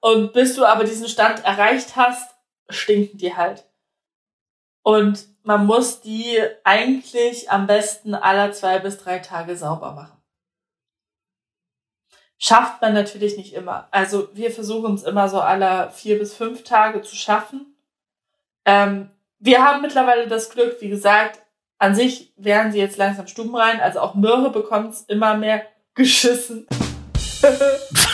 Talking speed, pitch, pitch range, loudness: 145 wpm, 215 Hz, 200-235 Hz, -18 LUFS